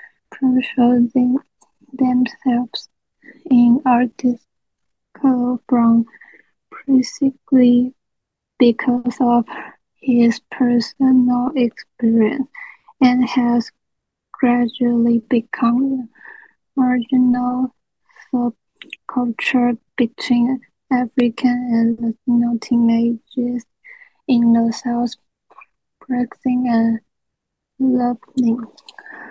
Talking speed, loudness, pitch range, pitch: 60 wpm, -18 LUFS, 240-260 Hz, 245 Hz